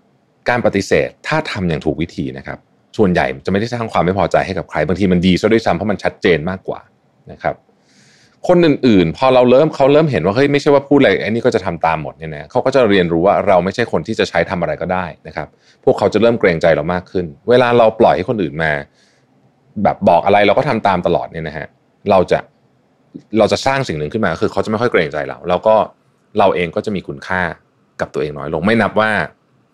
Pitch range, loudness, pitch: 90-125 Hz, -15 LUFS, 105 Hz